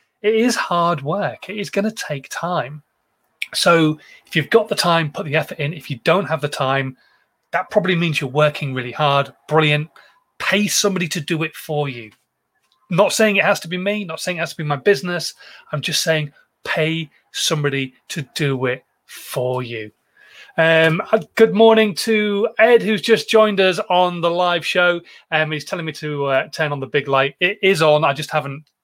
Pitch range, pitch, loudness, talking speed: 145-195 Hz, 160 Hz, -18 LUFS, 205 wpm